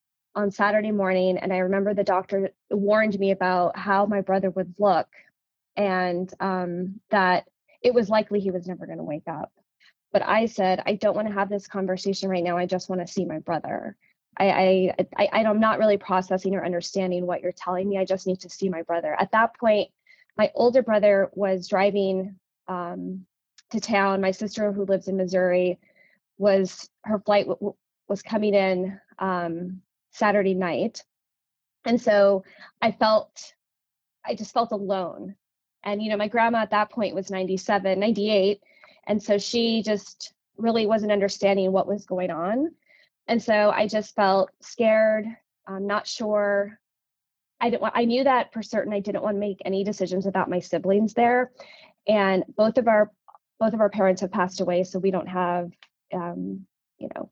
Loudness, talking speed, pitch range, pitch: -24 LUFS, 180 wpm, 185-215 Hz, 200 Hz